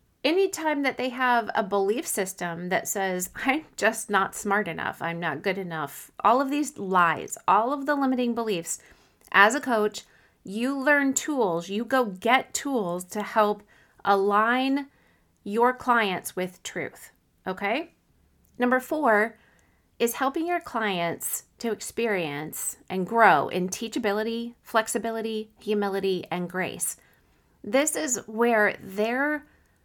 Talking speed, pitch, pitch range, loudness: 130 wpm, 220 Hz, 195-255 Hz, -26 LUFS